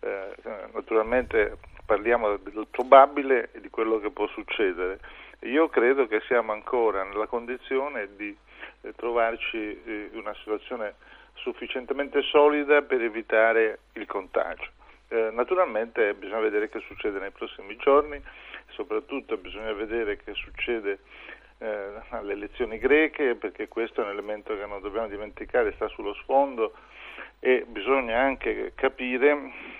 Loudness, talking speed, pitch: -26 LUFS, 120 wpm, 135 Hz